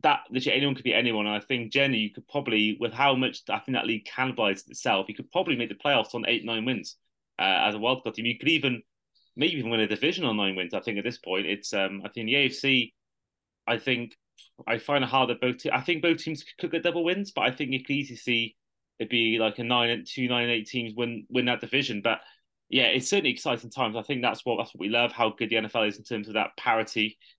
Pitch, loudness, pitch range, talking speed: 120 Hz, -26 LUFS, 110-135 Hz, 265 wpm